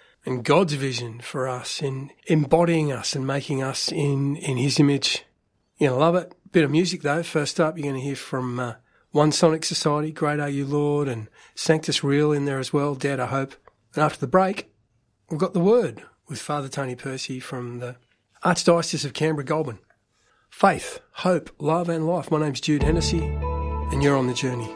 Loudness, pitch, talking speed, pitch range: -23 LUFS, 145 Hz, 195 wpm, 130-160 Hz